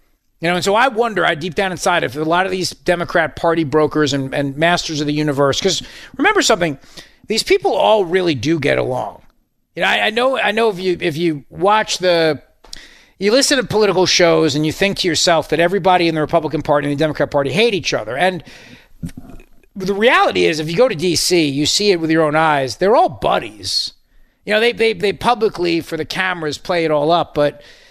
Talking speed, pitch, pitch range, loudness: 220 wpm, 170 Hz, 155-195 Hz, -16 LUFS